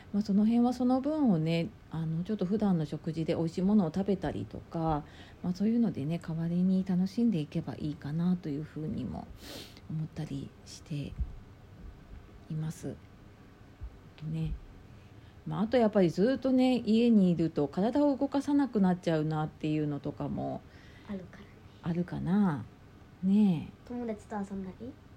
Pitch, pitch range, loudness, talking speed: 165 Hz, 140-205 Hz, -31 LUFS, 305 characters per minute